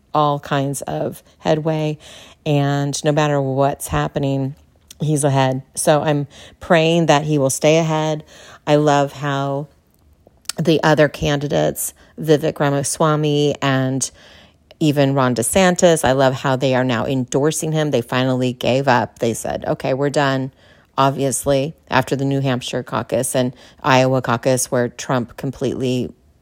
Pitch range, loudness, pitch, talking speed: 130-150 Hz, -18 LUFS, 140 Hz, 135 wpm